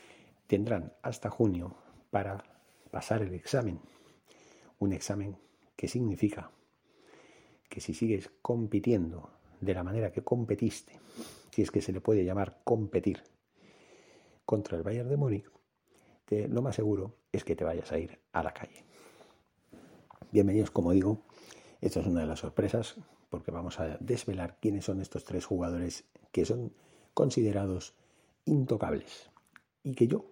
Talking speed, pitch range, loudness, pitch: 140 wpm, 95-115 Hz, -33 LUFS, 100 Hz